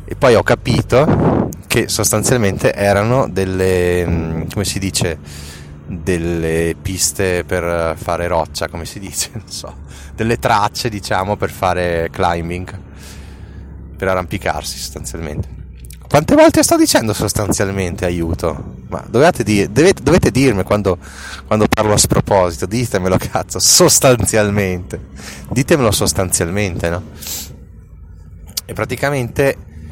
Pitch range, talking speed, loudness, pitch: 80-105 Hz, 110 wpm, -15 LUFS, 90 Hz